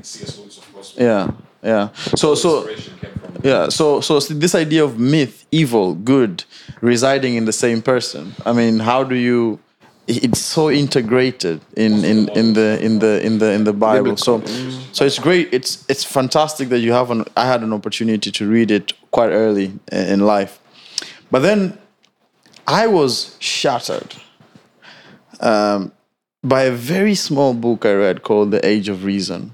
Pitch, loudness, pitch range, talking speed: 120 Hz, -16 LUFS, 110-135 Hz, 165 wpm